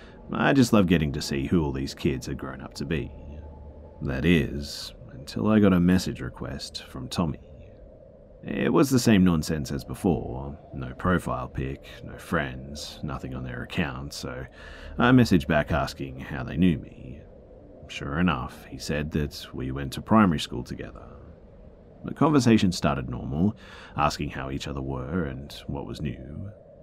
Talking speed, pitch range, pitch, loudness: 165 wpm, 70-90 Hz, 75 Hz, -26 LUFS